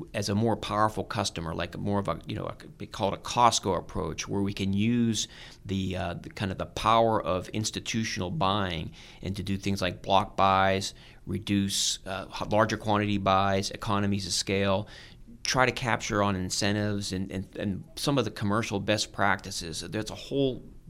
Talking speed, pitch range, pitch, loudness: 185 wpm, 95-110 Hz, 100 Hz, -28 LUFS